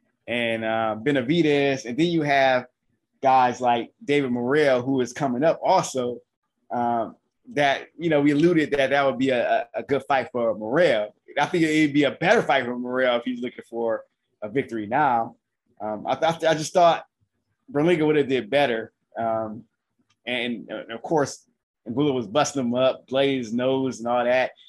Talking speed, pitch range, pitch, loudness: 180 wpm, 120-145 Hz, 130 Hz, -23 LUFS